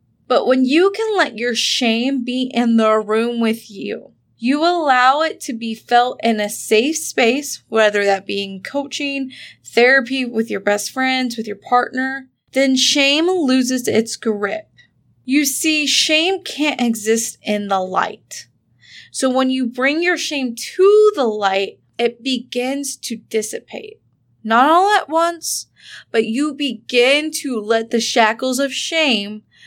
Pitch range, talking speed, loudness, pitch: 225-285 Hz, 150 wpm, -17 LUFS, 255 Hz